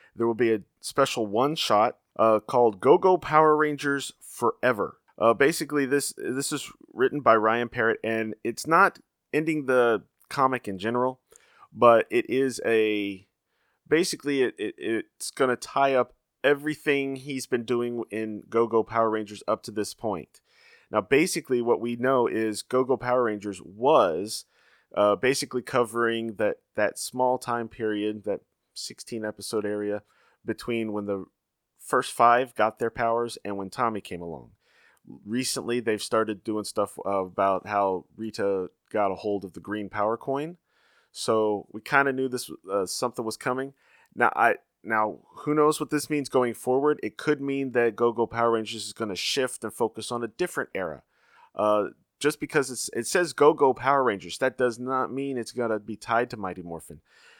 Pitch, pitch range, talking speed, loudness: 115 Hz, 105-135 Hz, 175 wpm, -26 LUFS